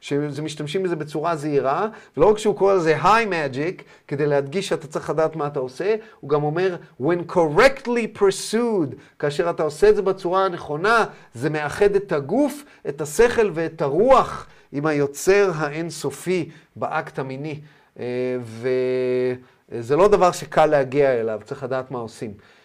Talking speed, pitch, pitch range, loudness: 145 wpm, 155 Hz, 140-195 Hz, -21 LUFS